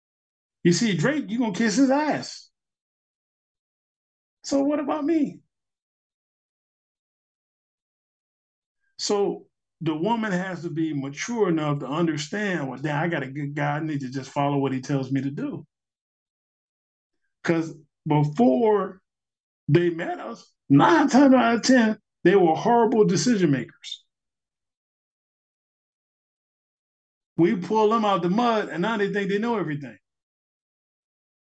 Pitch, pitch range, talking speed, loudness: 180 Hz, 145-230 Hz, 135 wpm, -23 LUFS